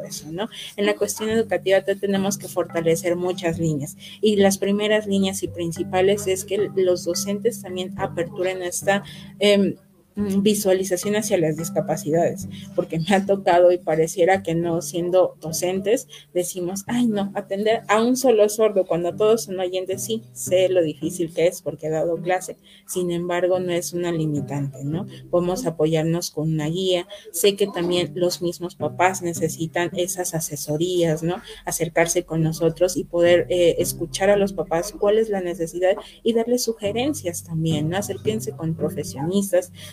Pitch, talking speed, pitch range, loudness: 180 Hz, 160 wpm, 165-195 Hz, -22 LUFS